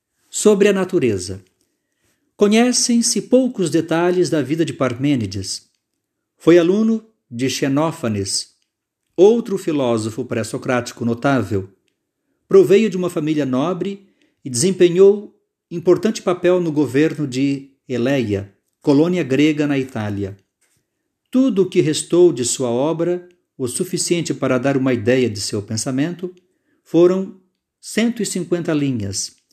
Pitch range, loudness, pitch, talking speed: 125-185 Hz, -18 LUFS, 155 Hz, 110 wpm